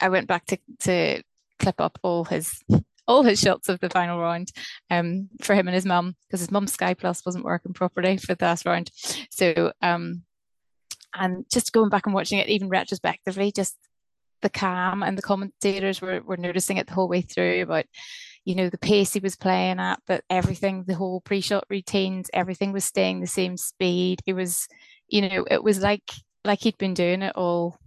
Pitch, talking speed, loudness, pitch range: 185 Hz, 200 wpm, -24 LUFS, 180-200 Hz